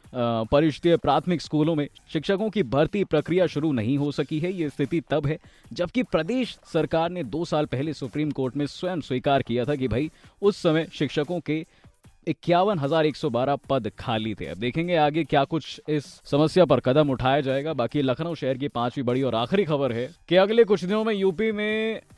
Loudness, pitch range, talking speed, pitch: -25 LUFS, 135-175 Hz, 180 wpm, 155 Hz